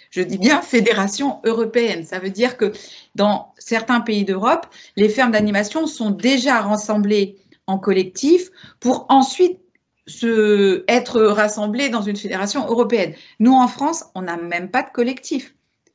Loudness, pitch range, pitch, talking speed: -18 LUFS, 205-260 Hz, 230 Hz, 145 wpm